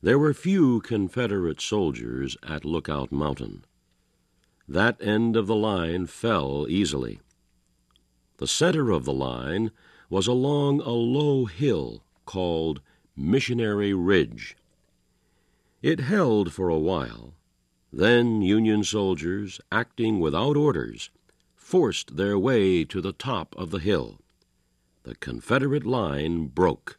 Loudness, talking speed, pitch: -25 LUFS, 115 wpm, 95 Hz